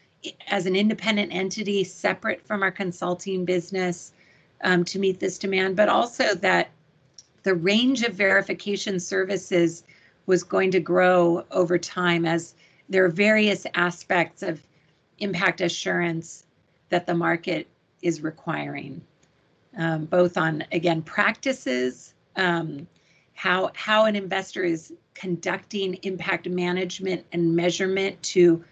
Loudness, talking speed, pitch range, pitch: -24 LUFS, 120 wpm, 170-190 Hz, 180 Hz